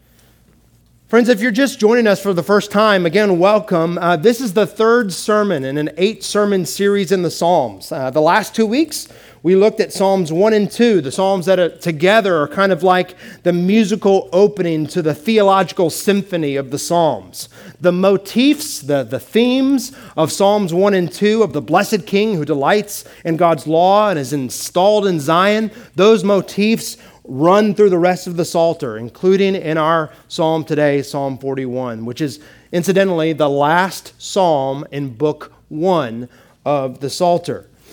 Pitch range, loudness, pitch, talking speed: 160-205 Hz, -15 LUFS, 185 Hz, 170 wpm